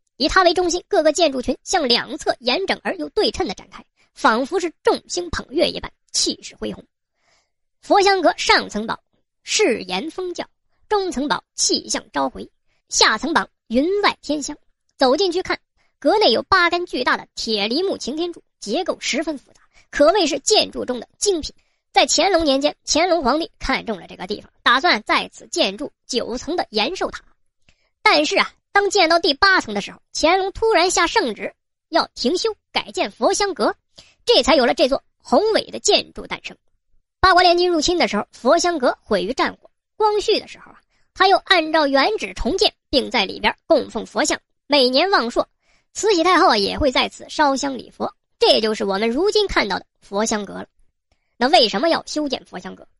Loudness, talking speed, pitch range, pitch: -19 LUFS, 270 characters per minute, 280-375 Hz, 335 Hz